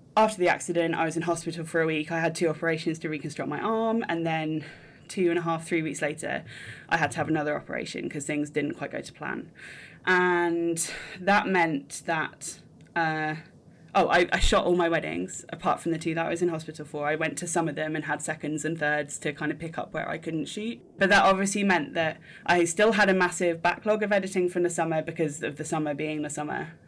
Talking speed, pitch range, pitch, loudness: 235 wpm, 155-175 Hz, 165 Hz, -27 LUFS